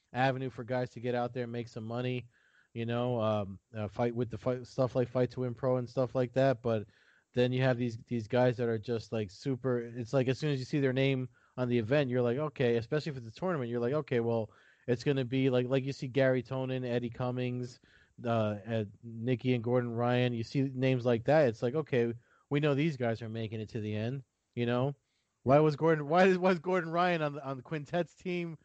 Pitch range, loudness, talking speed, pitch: 120-135 Hz, -32 LUFS, 245 wpm, 125 Hz